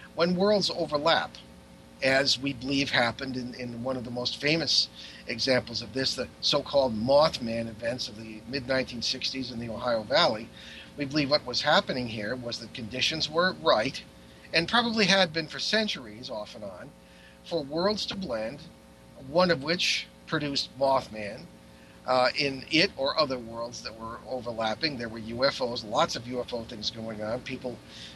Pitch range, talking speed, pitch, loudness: 110-145 Hz, 160 wpm, 125 Hz, -27 LUFS